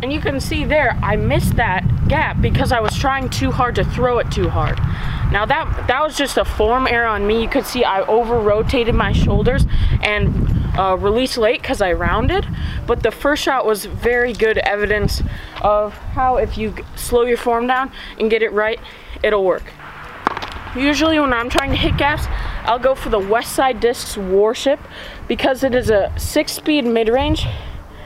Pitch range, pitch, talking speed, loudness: 215-260 Hz, 235 Hz, 190 wpm, -17 LUFS